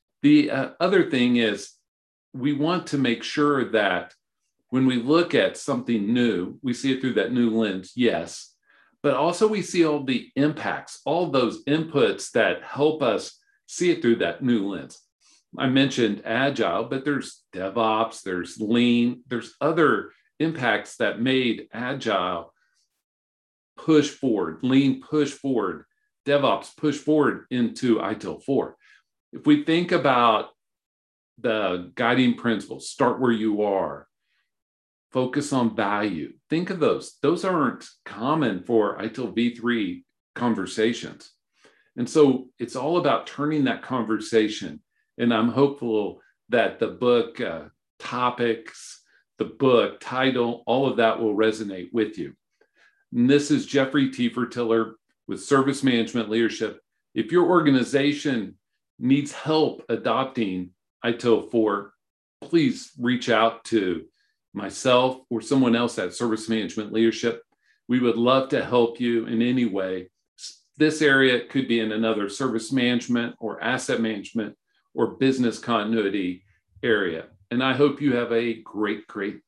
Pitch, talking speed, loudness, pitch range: 120 Hz, 135 wpm, -23 LUFS, 110-135 Hz